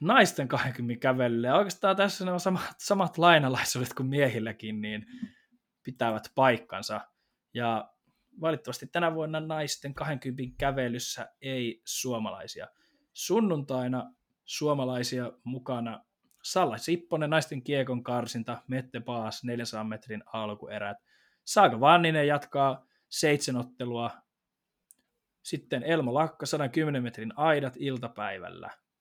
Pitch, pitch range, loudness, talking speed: 130 Hz, 120-160 Hz, -29 LUFS, 100 wpm